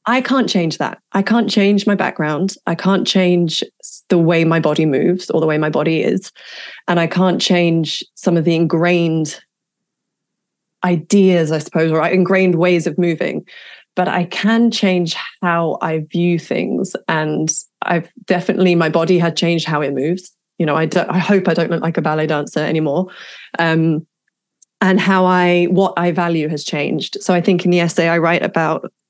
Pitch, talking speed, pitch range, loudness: 175 Hz, 185 wpm, 165-185 Hz, -16 LUFS